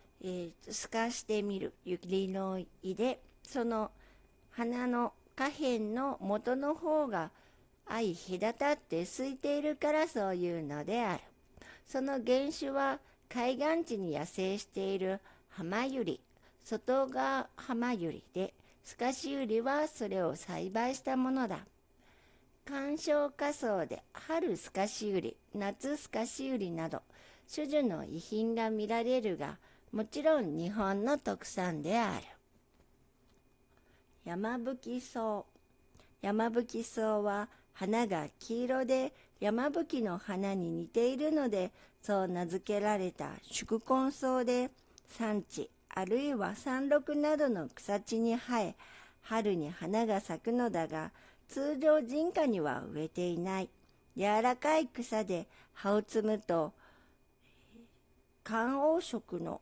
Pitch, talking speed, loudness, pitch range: 230 Hz, 215 characters per minute, -35 LUFS, 195-265 Hz